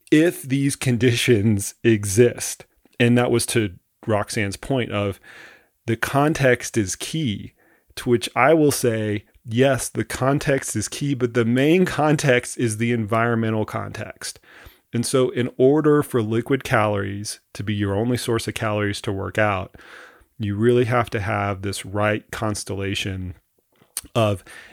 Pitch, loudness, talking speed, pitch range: 115 Hz, -21 LUFS, 145 wpm, 105-125 Hz